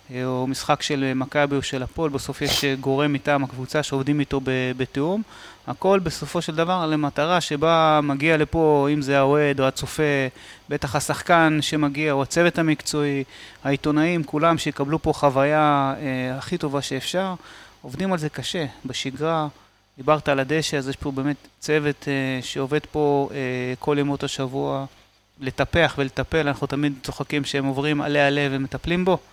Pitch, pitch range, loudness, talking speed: 145 Hz, 135-155 Hz, -22 LUFS, 155 wpm